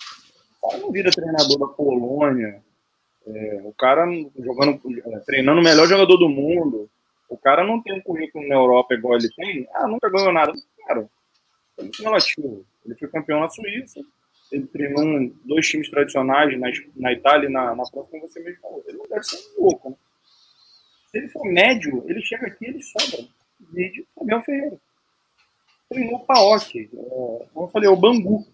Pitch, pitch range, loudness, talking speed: 165 Hz, 135-225 Hz, -19 LUFS, 180 wpm